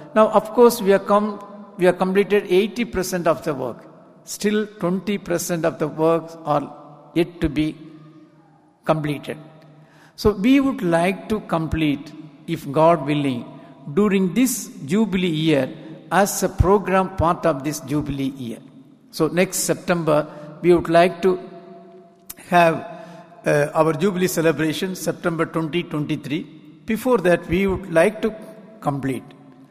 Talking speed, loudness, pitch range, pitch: 130 wpm, -20 LUFS, 155-195 Hz, 170 Hz